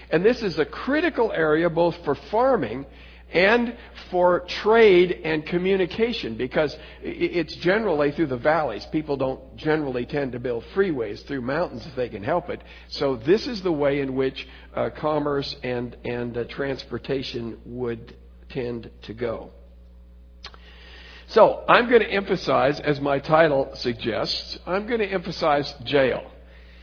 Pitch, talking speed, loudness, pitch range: 140 Hz, 145 wpm, -23 LUFS, 120-175 Hz